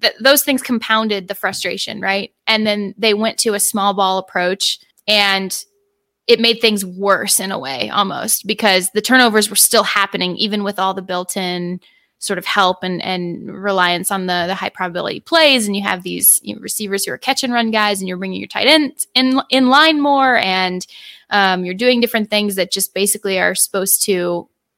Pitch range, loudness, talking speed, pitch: 190-230 Hz, -15 LUFS, 205 wpm, 200 Hz